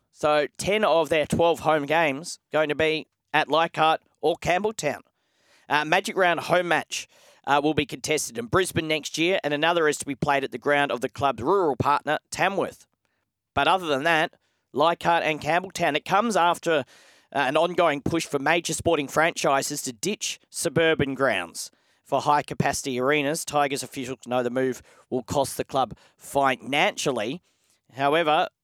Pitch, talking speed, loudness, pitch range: 155 Hz, 165 wpm, -24 LUFS, 140-170 Hz